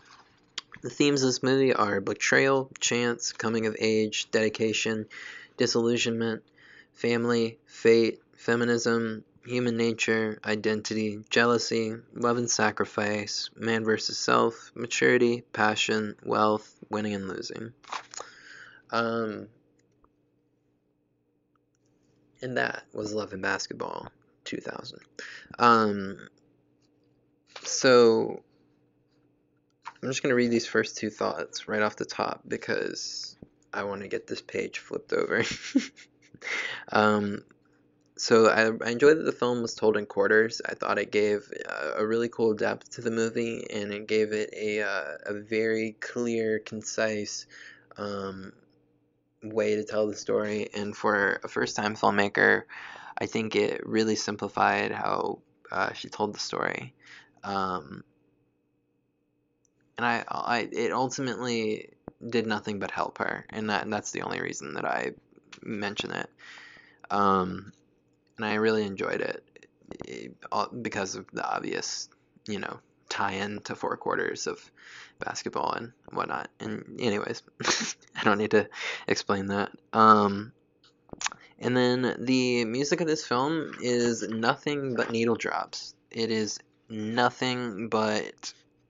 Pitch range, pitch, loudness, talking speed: 95-120 Hz, 110 Hz, -28 LUFS, 130 wpm